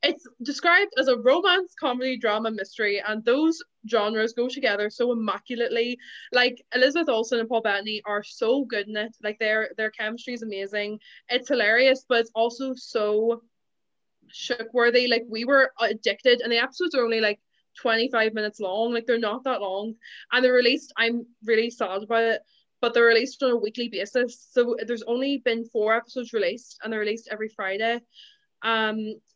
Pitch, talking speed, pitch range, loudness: 235 Hz, 175 wpm, 215-250 Hz, -24 LUFS